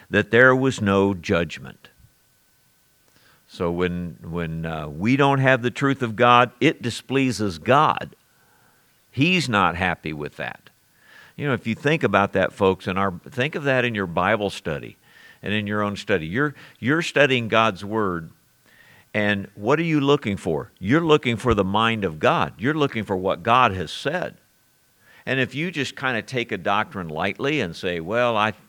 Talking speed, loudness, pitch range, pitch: 175 wpm, -22 LUFS, 95-130 Hz, 110 Hz